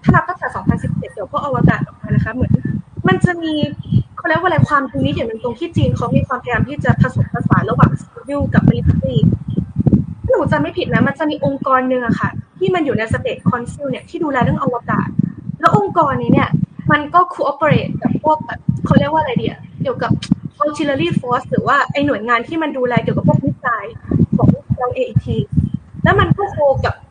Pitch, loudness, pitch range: 285 Hz, -16 LUFS, 240-320 Hz